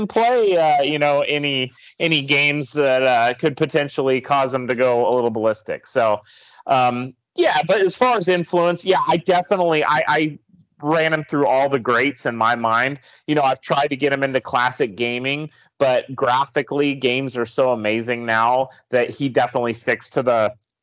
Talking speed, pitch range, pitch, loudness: 180 wpm, 125-155 Hz, 140 Hz, -19 LUFS